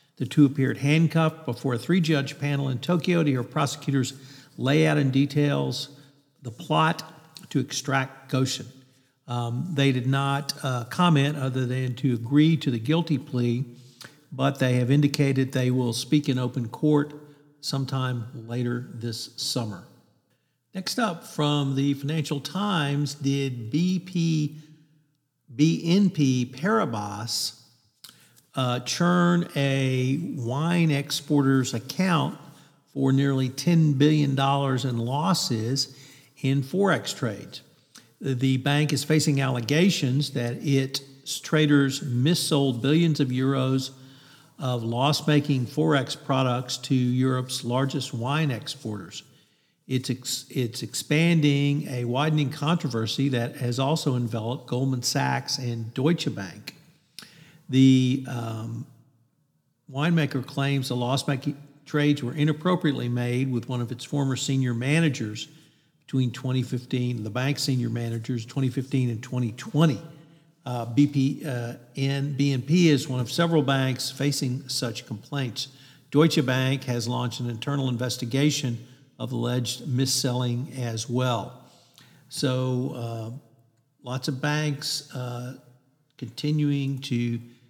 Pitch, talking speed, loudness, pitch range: 135 Hz, 120 wpm, -25 LUFS, 125-150 Hz